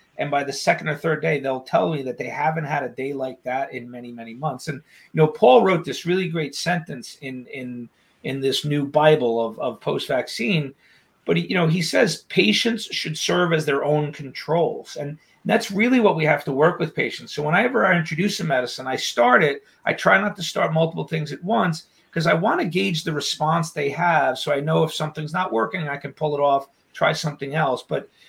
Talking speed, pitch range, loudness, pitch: 225 wpm, 140-170 Hz, -21 LUFS, 155 Hz